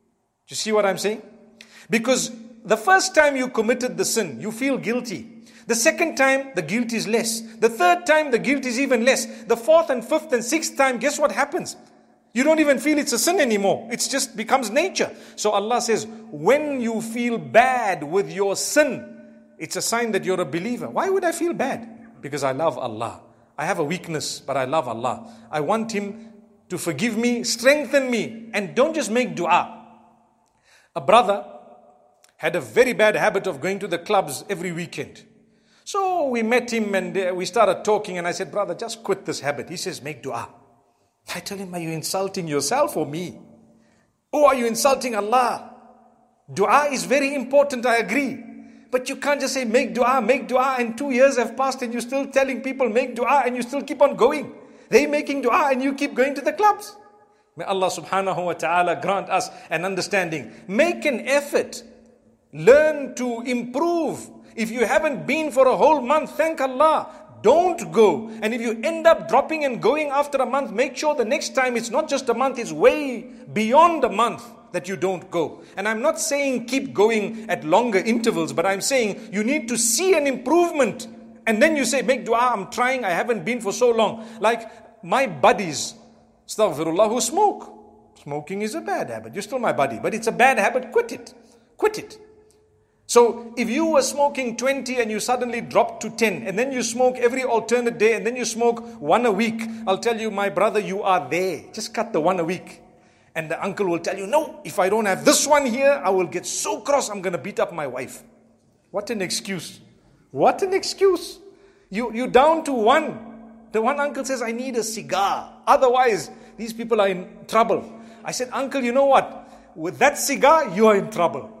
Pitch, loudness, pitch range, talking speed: 235 Hz, -21 LUFS, 200-270 Hz, 200 wpm